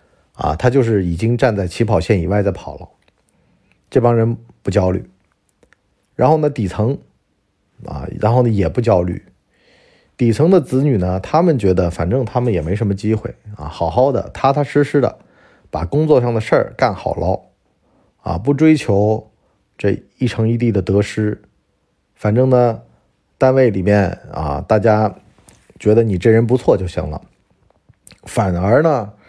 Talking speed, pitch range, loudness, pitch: 225 characters per minute, 95-125 Hz, -16 LUFS, 110 Hz